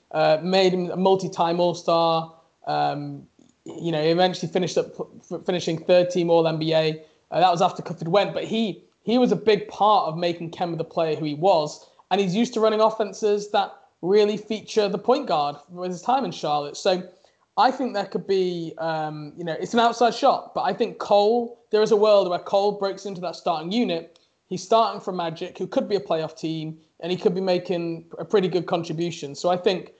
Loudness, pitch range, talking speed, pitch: -23 LUFS, 165-205 Hz, 210 wpm, 180 Hz